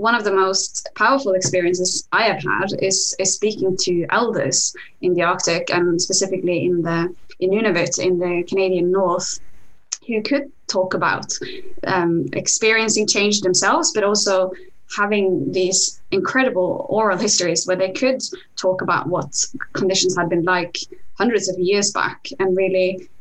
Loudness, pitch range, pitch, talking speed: -19 LUFS, 180-215 Hz, 190 Hz, 150 wpm